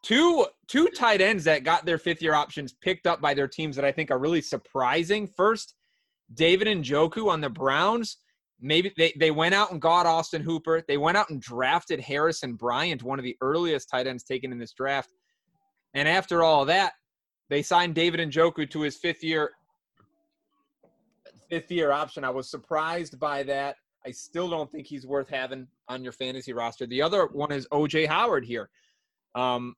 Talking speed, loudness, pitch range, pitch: 185 wpm, -26 LUFS, 140-175 Hz, 160 Hz